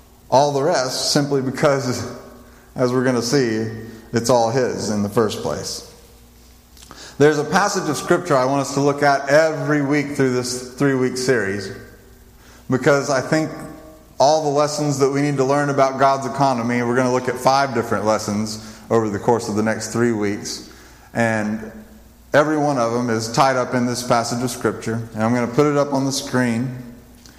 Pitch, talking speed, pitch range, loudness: 125 Hz, 195 wpm, 110-140 Hz, -19 LUFS